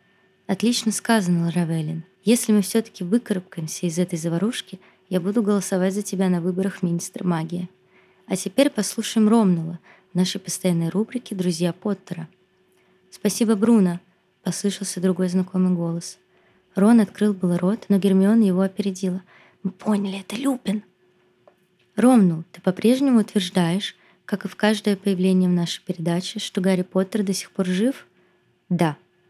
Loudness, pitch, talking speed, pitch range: -22 LUFS, 190 Hz, 135 wpm, 180-210 Hz